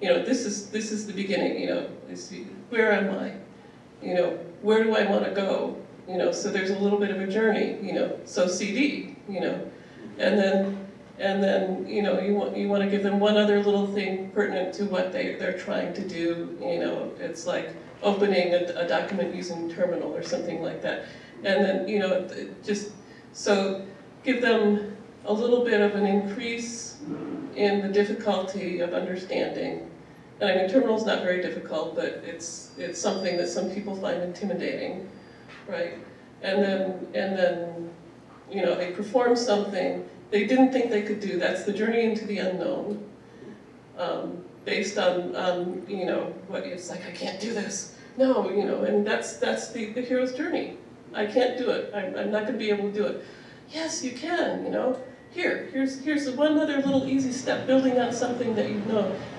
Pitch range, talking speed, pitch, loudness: 185-230 Hz, 190 wpm, 205 Hz, -27 LUFS